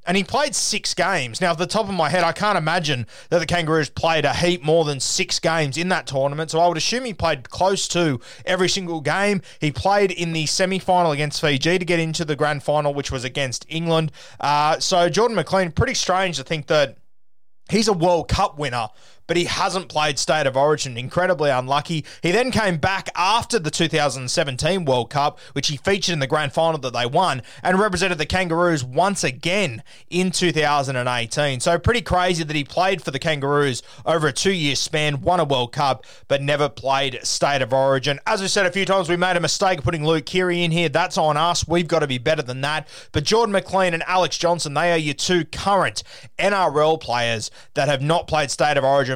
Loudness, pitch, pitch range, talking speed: -20 LUFS, 165 Hz, 145-180 Hz, 210 wpm